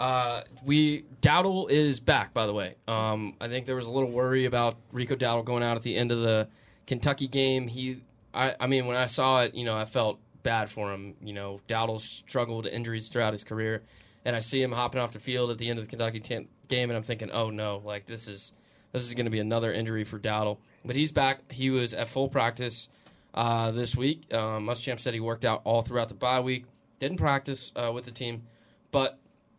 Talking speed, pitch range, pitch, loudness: 225 wpm, 110-130 Hz, 120 Hz, -29 LUFS